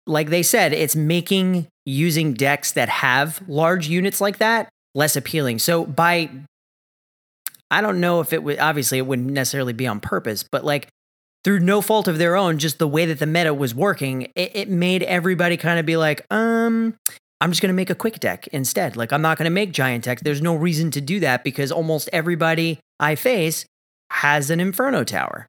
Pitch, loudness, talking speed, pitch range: 165 Hz, -20 LUFS, 200 wpm, 145-180 Hz